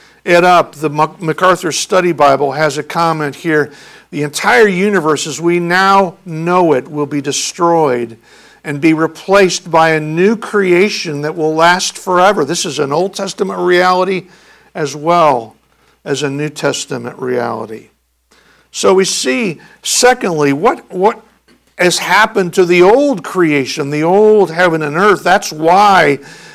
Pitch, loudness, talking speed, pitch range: 170 Hz, -12 LUFS, 145 wpm, 150-185 Hz